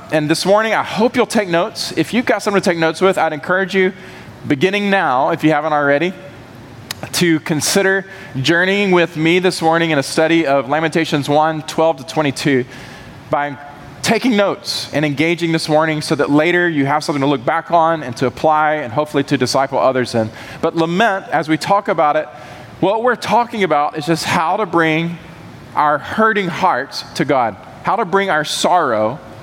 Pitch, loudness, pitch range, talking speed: 160 Hz, -16 LUFS, 145-185 Hz, 190 wpm